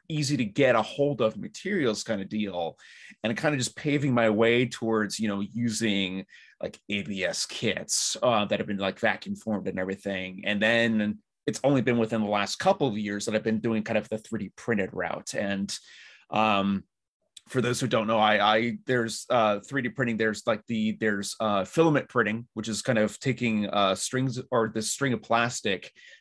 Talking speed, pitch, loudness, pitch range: 195 wpm, 110 Hz, -27 LUFS, 105-125 Hz